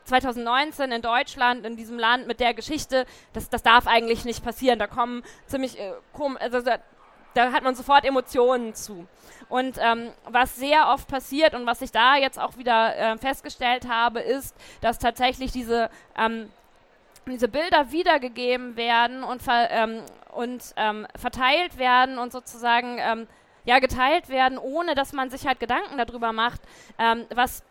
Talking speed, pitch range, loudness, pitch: 160 wpm, 235-260 Hz, -23 LUFS, 245 Hz